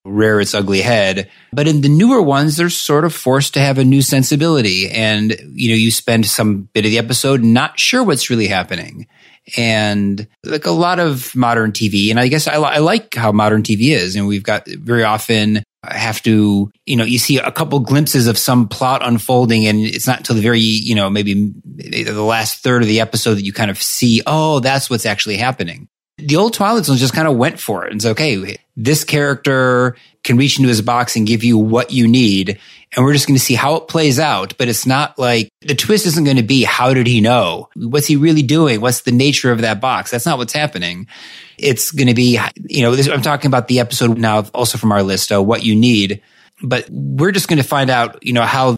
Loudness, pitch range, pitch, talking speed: -14 LUFS, 110-140 Hz, 120 Hz, 230 wpm